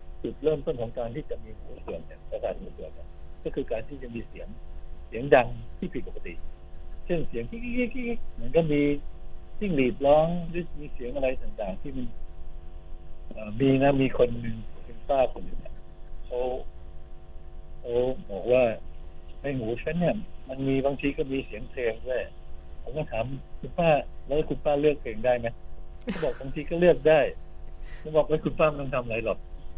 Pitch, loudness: 120 Hz, -28 LUFS